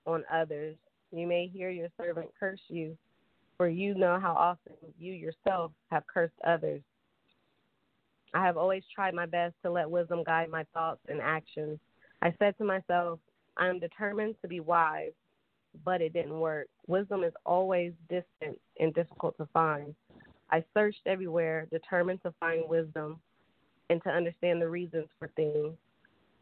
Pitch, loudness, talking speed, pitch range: 170 Hz, -32 LUFS, 155 wpm, 160-180 Hz